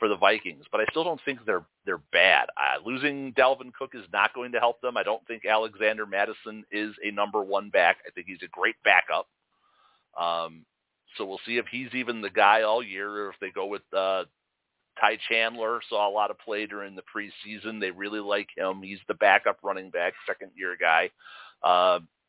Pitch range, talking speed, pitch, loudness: 100-120 Hz, 210 wpm, 105 Hz, -26 LUFS